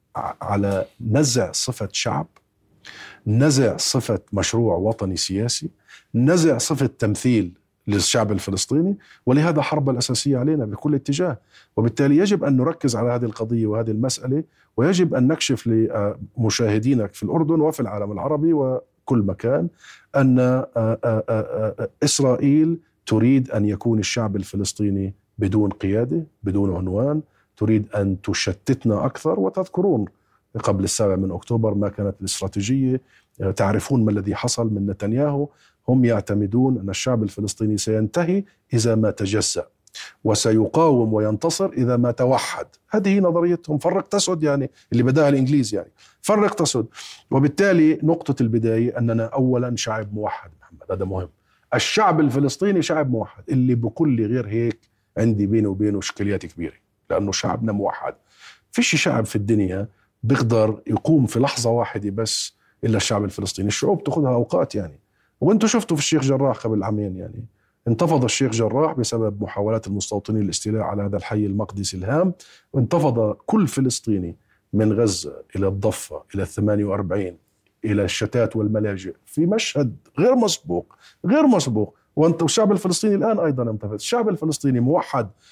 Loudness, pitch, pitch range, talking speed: -21 LUFS, 115 Hz, 105-145 Hz, 130 wpm